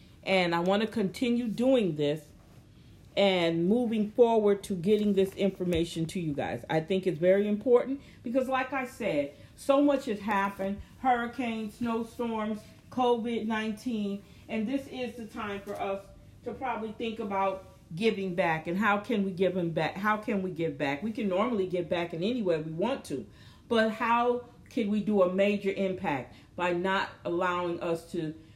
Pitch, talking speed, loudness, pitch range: 205 Hz, 170 wpm, -29 LUFS, 185-235 Hz